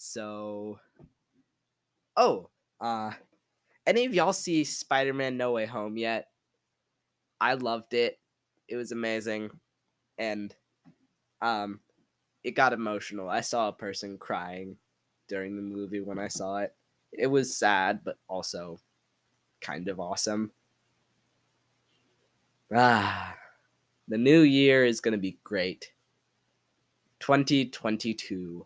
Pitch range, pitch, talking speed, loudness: 100-125 Hz, 110 Hz, 110 wpm, -28 LUFS